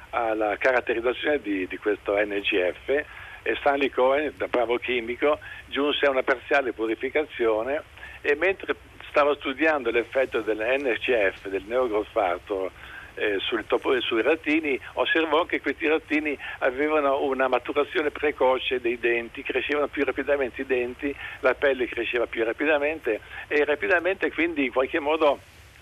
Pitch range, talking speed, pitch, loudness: 120-150 Hz, 130 wpm, 140 Hz, -25 LUFS